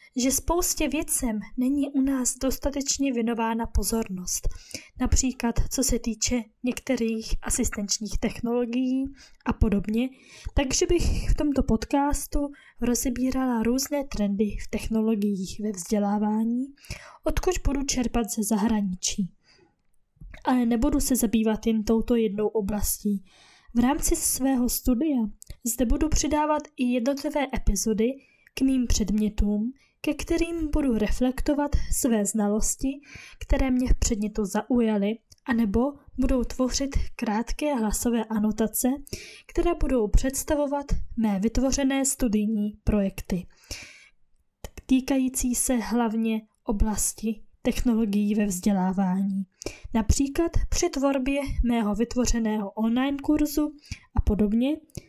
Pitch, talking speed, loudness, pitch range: 245 Hz, 105 wpm, -26 LUFS, 220-275 Hz